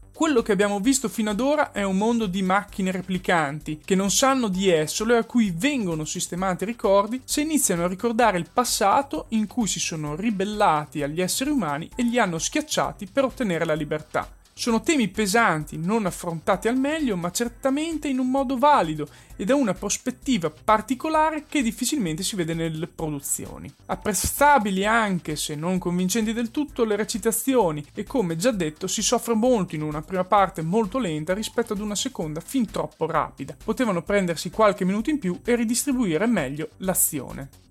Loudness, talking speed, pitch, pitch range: -23 LUFS, 175 wpm, 210 Hz, 175-245 Hz